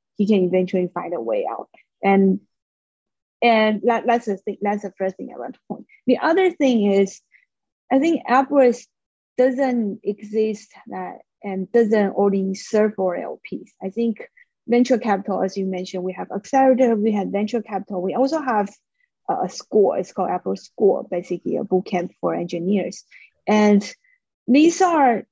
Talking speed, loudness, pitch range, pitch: 165 wpm, -20 LUFS, 195-255 Hz, 215 Hz